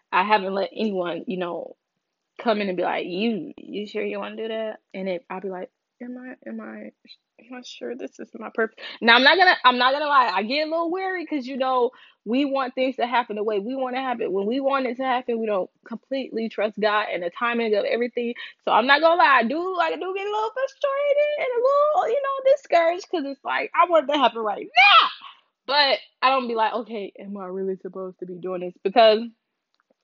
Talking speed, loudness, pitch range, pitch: 245 wpm, -22 LUFS, 210-285 Hz, 240 Hz